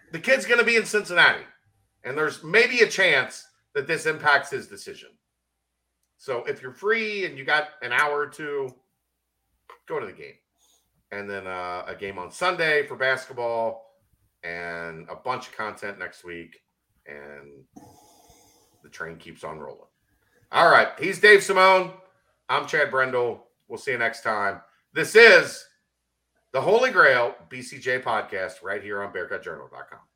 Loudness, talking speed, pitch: -22 LUFS, 155 wpm, 130 Hz